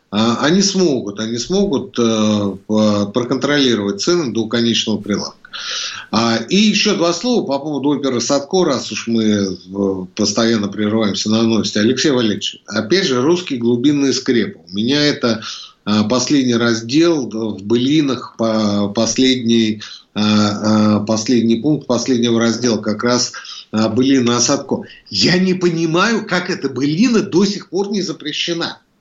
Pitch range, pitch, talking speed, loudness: 110-150 Hz, 120 Hz, 120 wpm, -16 LUFS